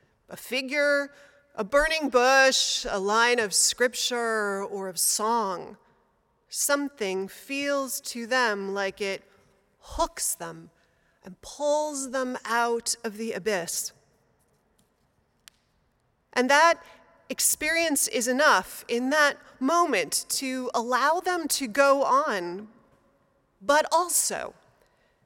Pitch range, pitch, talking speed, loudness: 215-285 Hz, 255 Hz, 100 wpm, -25 LUFS